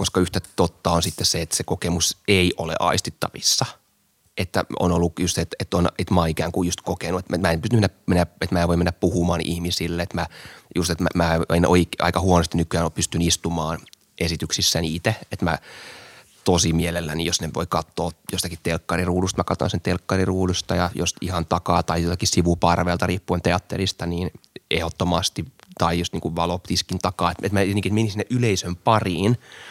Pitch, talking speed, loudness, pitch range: 90 Hz, 185 wpm, -22 LUFS, 85-95 Hz